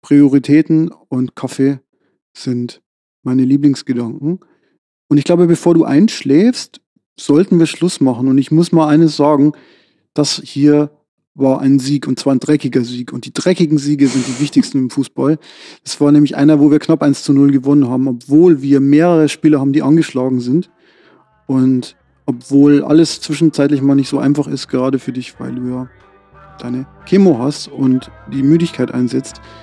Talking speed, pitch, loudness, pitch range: 170 wpm, 145 Hz, -13 LUFS, 130-155 Hz